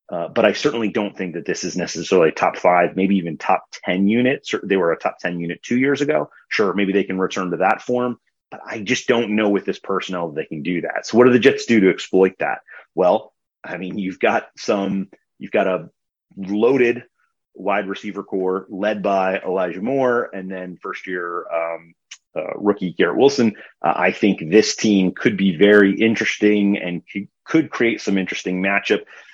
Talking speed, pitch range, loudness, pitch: 200 wpm, 95-110 Hz, -19 LUFS, 100 Hz